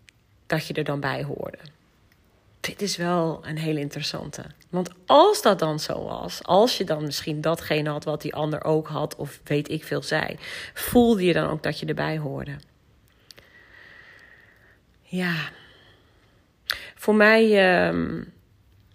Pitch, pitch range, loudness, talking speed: 155 Hz, 145-180 Hz, -24 LUFS, 145 wpm